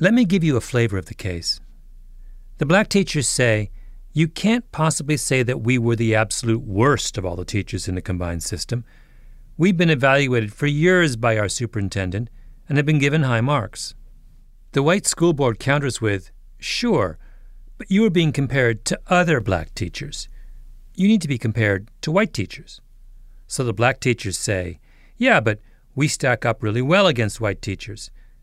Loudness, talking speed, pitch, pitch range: -20 LUFS, 175 wpm, 120 Hz, 110-150 Hz